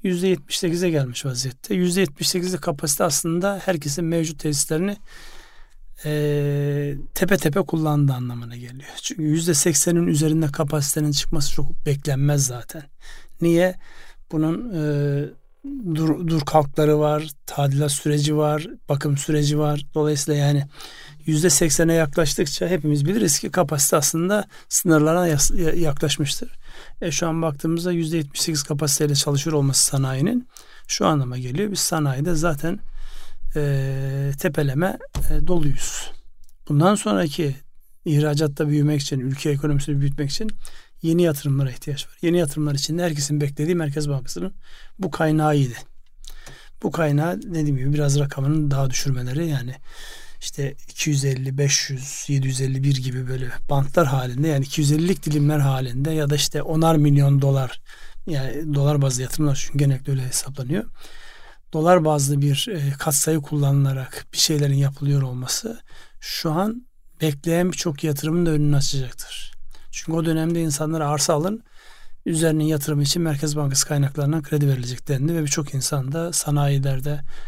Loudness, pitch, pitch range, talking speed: -21 LUFS, 150 Hz, 140-165 Hz, 125 wpm